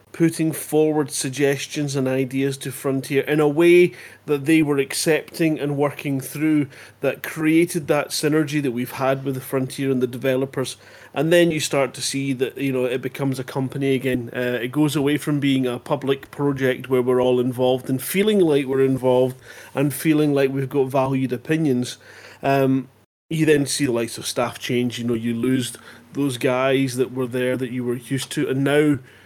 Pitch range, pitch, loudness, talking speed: 130-150 Hz, 135 Hz, -21 LUFS, 195 wpm